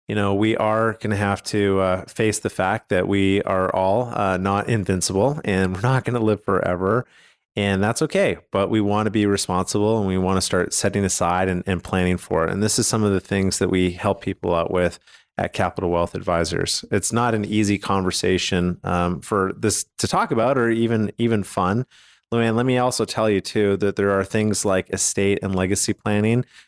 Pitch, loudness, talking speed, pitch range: 100 Hz, -21 LUFS, 215 wpm, 95-110 Hz